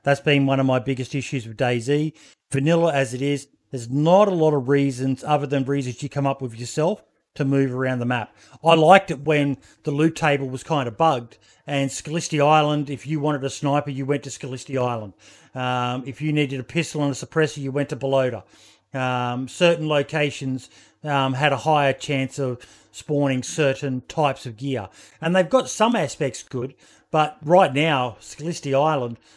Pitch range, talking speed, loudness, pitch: 130-150 Hz, 190 wpm, -22 LUFS, 140 Hz